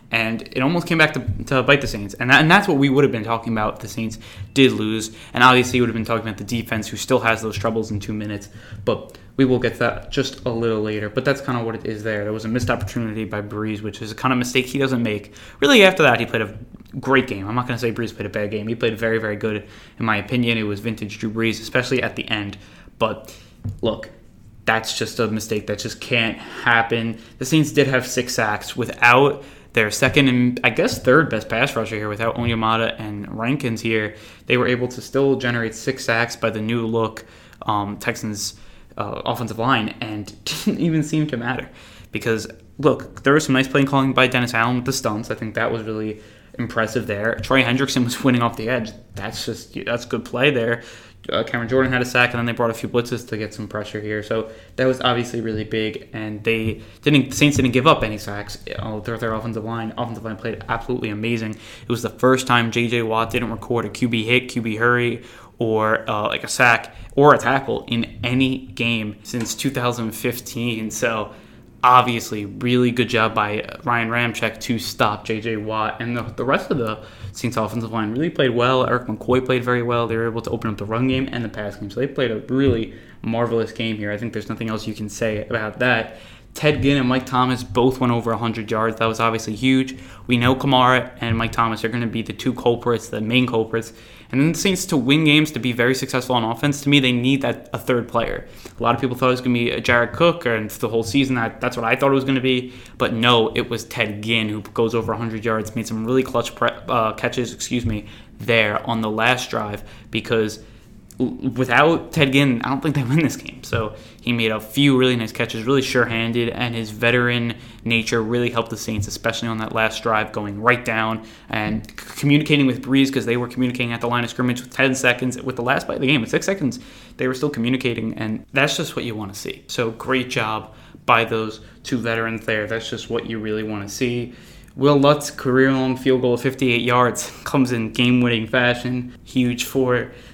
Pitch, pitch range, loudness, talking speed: 115 Hz, 110-125 Hz, -20 LUFS, 235 wpm